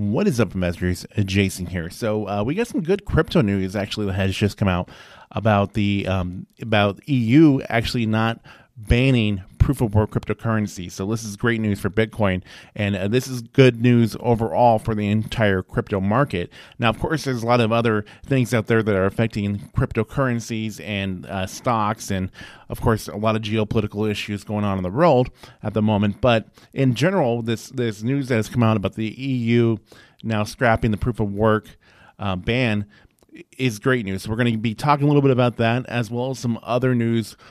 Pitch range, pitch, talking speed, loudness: 105-120 Hz, 110 Hz, 200 wpm, -21 LUFS